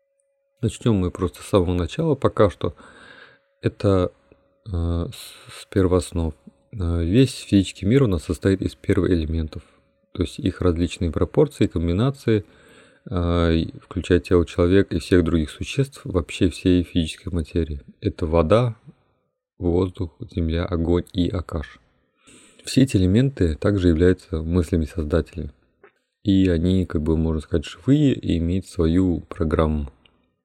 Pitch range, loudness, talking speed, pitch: 85-100 Hz, -22 LUFS, 125 wpm, 90 Hz